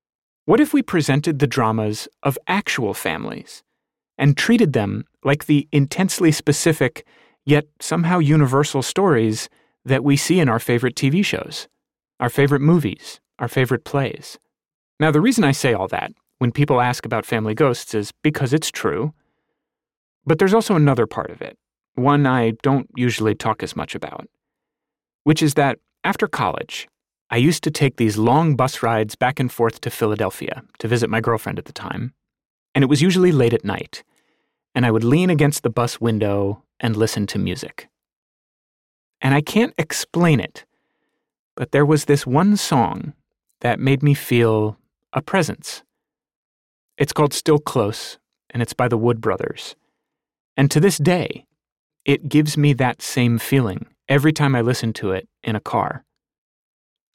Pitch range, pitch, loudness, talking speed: 115-150 Hz, 135 Hz, -19 LUFS, 165 wpm